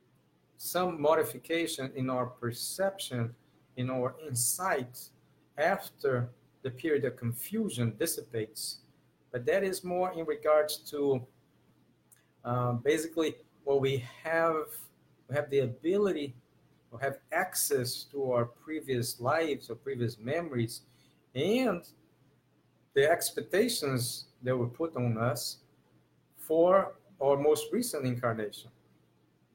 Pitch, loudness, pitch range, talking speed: 135 Hz, -32 LUFS, 120-155 Hz, 110 wpm